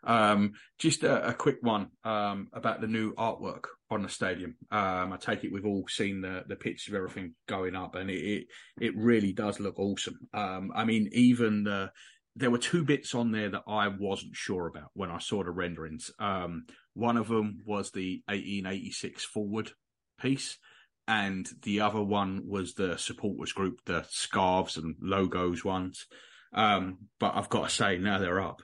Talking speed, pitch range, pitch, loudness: 185 wpm, 95-110 Hz, 100 Hz, -31 LUFS